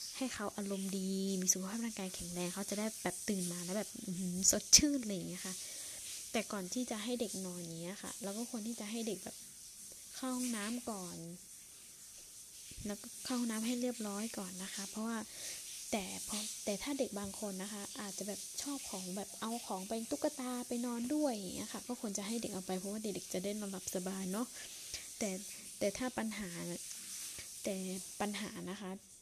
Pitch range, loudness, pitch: 190-230 Hz, -39 LUFS, 205 Hz